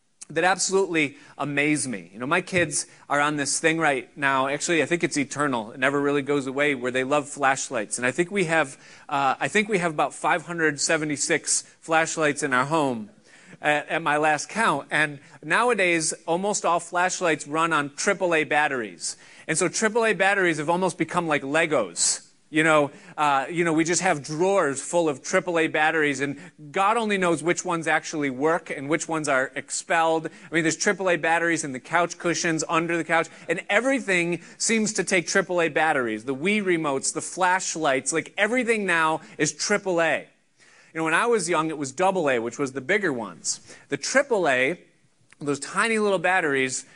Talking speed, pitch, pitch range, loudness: 180 wpm, 160 Hz, 145-180 Hz, -23 LUFS